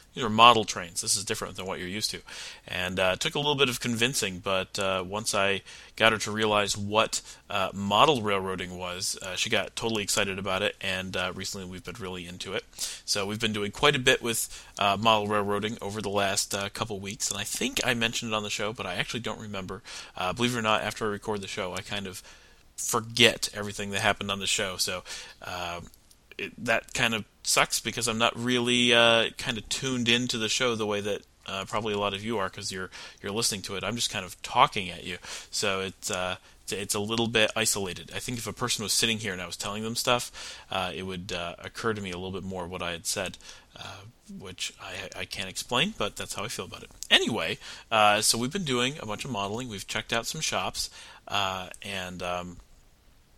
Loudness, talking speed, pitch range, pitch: -27 LUFS, 235 wpm, 95-115 Hz, 105 Hz